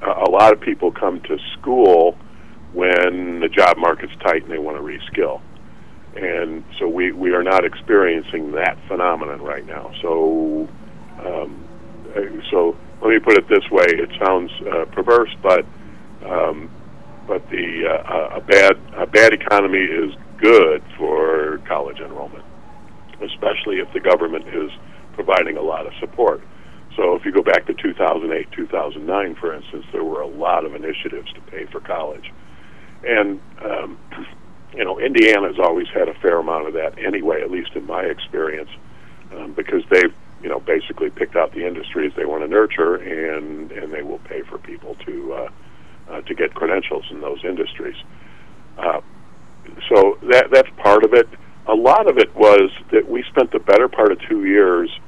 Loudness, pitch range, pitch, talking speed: -17 LUFS, 340-435 Hz, 395 Hz, 170 wpm